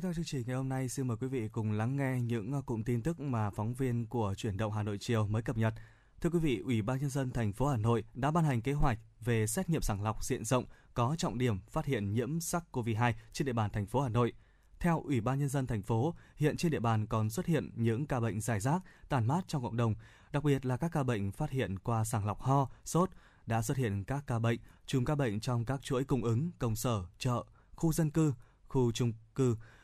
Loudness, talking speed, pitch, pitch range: -34 LUFS, 255 wpm, 125 Hz, 115-140 Hz